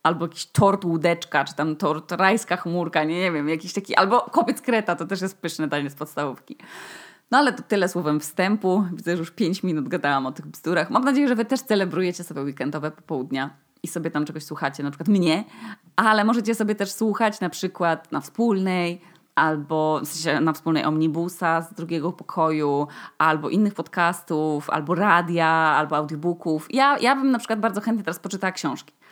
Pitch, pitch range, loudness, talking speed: 170 Hz, 155-200 Hz, -23 LUFS, 190 wpm